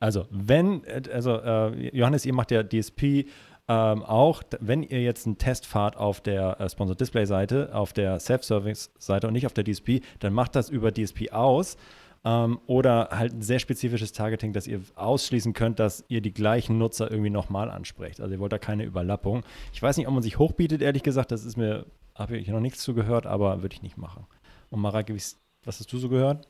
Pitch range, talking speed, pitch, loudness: 105-125 Hz, 200 wpm, 110 Hz, -26 LUFS